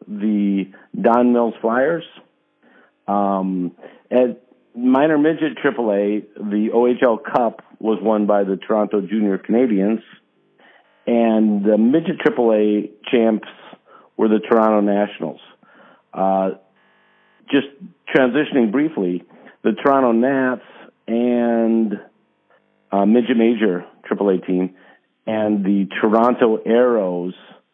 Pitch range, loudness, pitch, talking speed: 100-120 Hz, -18 LUFS, 110 Hz, 95 wpm